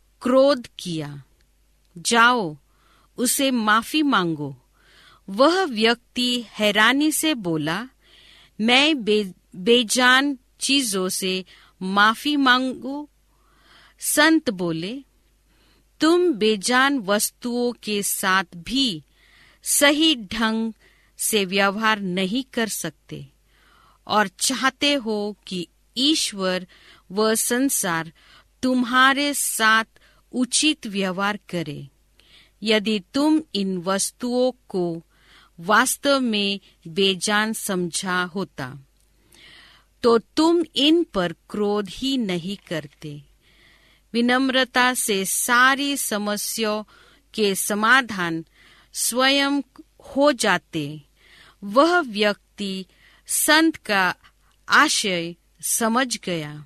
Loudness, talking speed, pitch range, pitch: -21 LUFS, 85 wpm, 185-260 Hz, 220 Hz